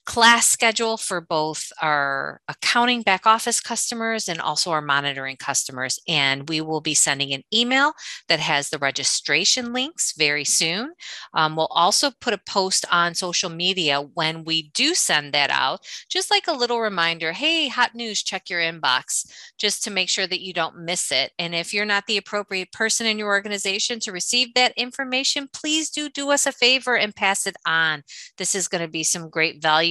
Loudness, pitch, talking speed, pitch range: -21 LUFS, 190 Hz, 190 wpm, 160-235 Hz